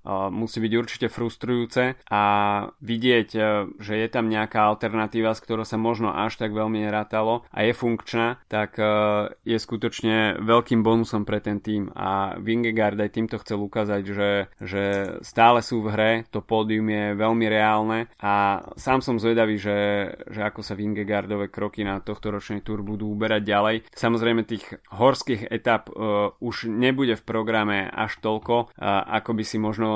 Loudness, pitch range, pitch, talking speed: -24 LUFS, 105-115 Hz, 110 Hz, 160 wpm